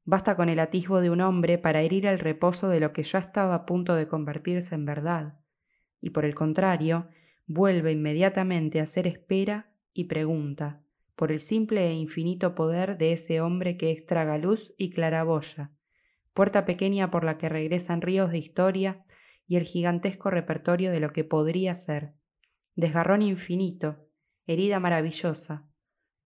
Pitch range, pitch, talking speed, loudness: 160-185 Hz, 170 Hz, 160 wpm, -27 LUFS